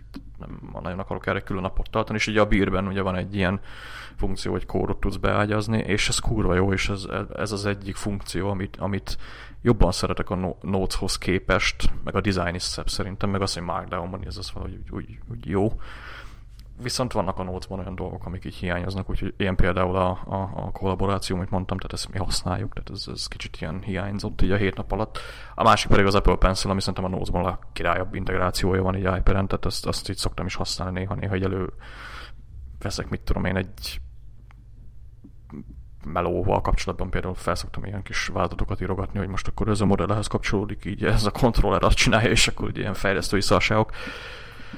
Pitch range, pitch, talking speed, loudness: 90-100 Hz, 95 Hz, 195 wpm, -25 LUFS